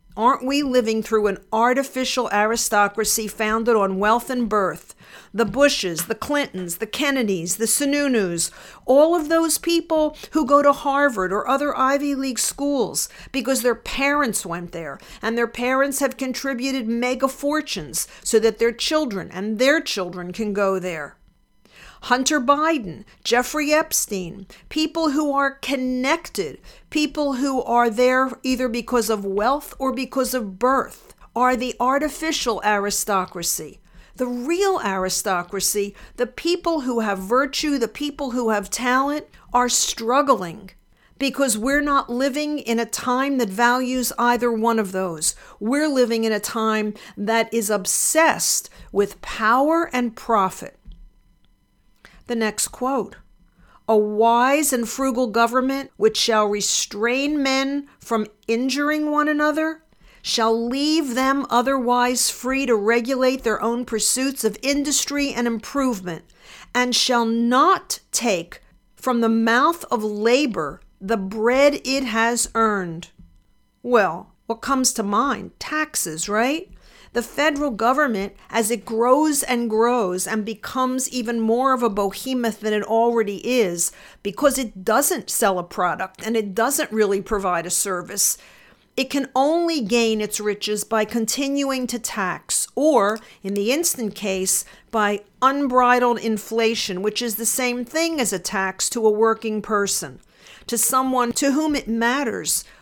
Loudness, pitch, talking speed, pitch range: -21 LUFS, 240 Hz, 140 wpm, 215-275 Hz